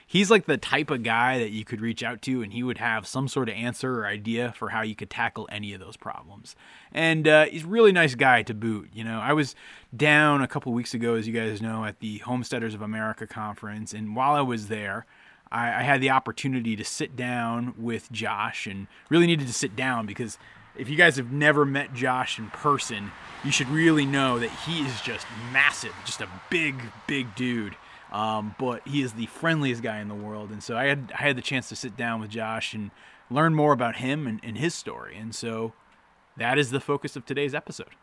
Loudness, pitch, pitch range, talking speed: -25 LUFS, 120 Hz, 110-140 Hz, 230 wpm